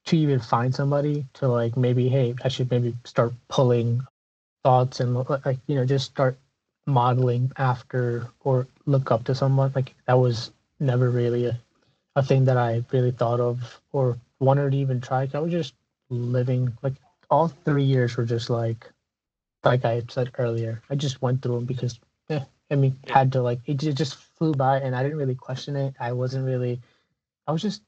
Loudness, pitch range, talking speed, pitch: -24 LUFS, 120-135 Hz, 190 wpm, 130 Hz